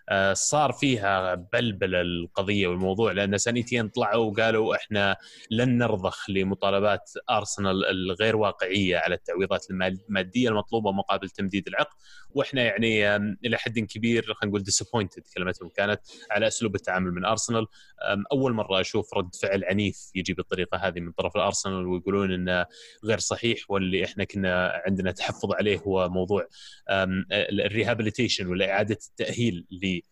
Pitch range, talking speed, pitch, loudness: 95-115 Hz, 135 wpm, 100 Hz, -26 LUFS